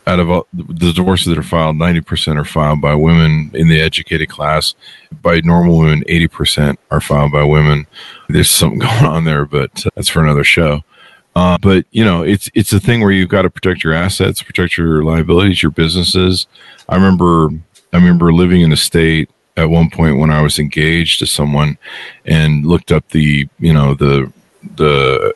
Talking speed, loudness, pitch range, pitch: 195 wpm, -12 LUFS, 75-90 Hz, 80 Hz